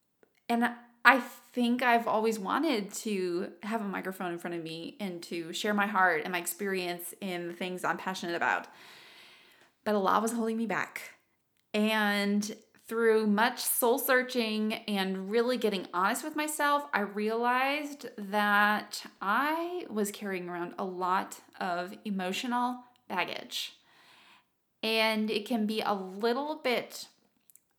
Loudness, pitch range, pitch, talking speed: -30 LUFS, 190-240 Hz, 215 Hz, 140 wpm